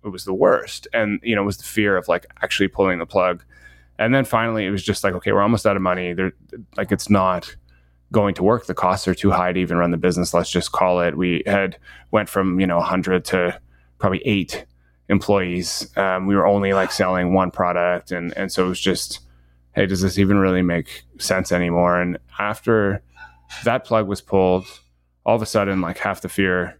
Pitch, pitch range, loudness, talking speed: 90 Hz, 85-100 Hz, -20 LUFS, 220 wpm